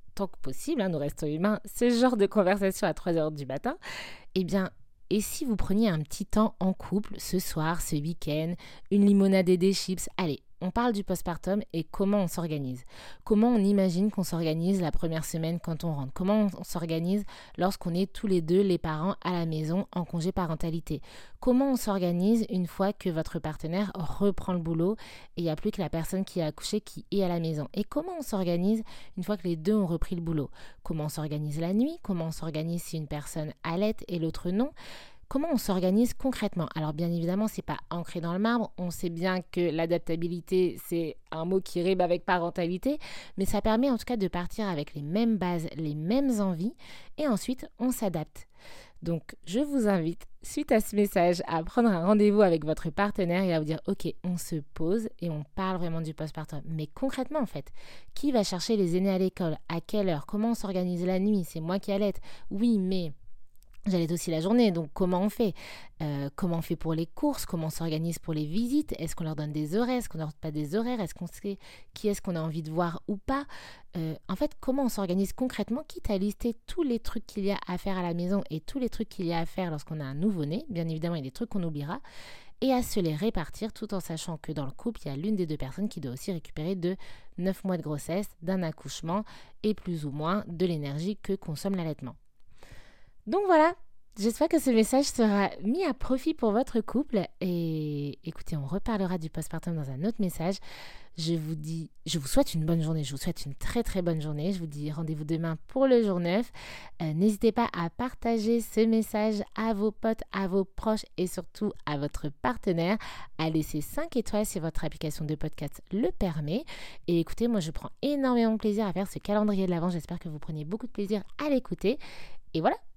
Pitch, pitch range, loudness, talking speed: 185 Hz, 165-210 Hz, -30 LUFS, 220 wpm